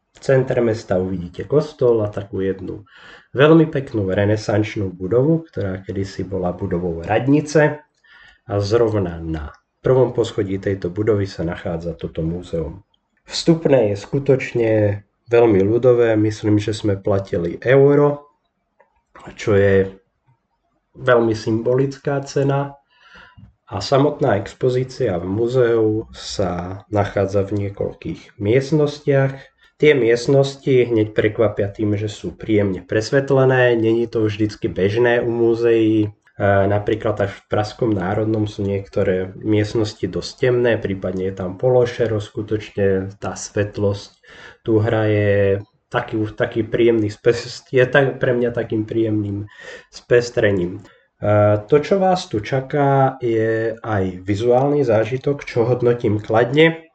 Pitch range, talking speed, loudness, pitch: 100-125 Hz, 115 wpm, -19 LUFS, 110 Hz